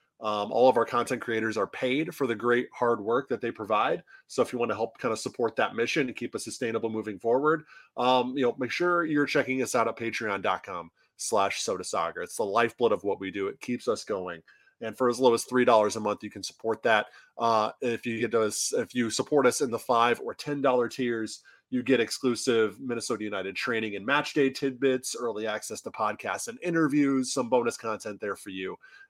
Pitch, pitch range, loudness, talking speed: 120 Hz, 110-135 Hz, -28 LUFS, 220 wpm